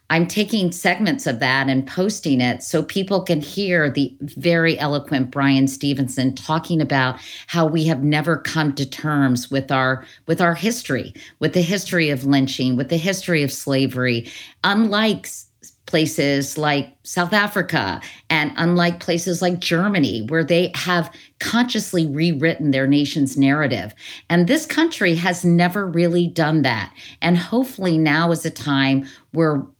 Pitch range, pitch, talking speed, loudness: 140-175 Hz, 160 Hz, 150 wpm, -19 LUFS